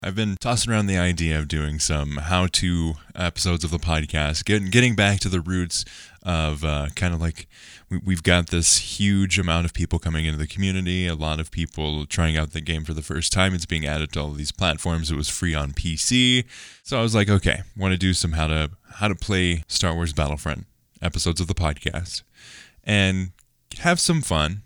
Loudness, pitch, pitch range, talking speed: -22 LUFS, 85 Hz, 80-95 Hz, 205 wpm